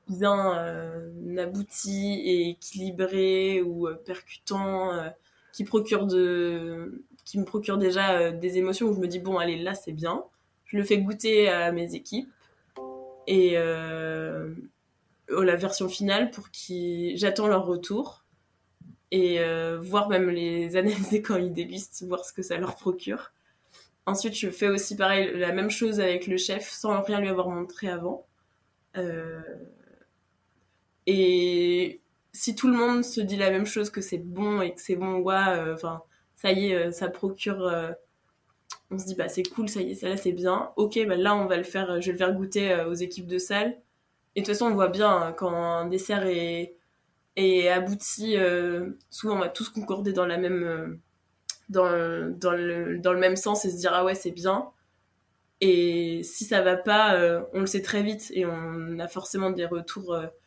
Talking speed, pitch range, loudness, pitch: 190 wpm, 175-200 Hz, -26 LUFS, 185 Hz